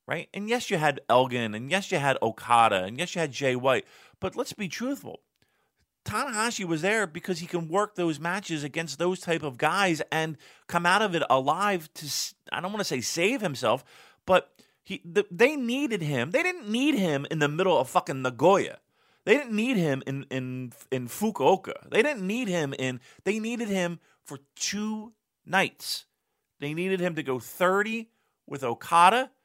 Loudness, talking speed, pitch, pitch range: -27 LUFS, 185 wpm, 175 Hz, 140-205 Hz